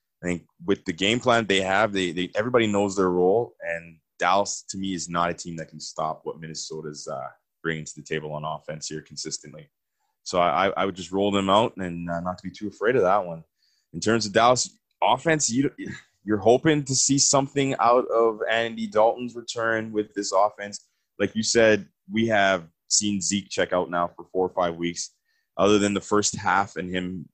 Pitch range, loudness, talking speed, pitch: 85-115 Hz, -24 LUFS, 210 wpm, 100 Hz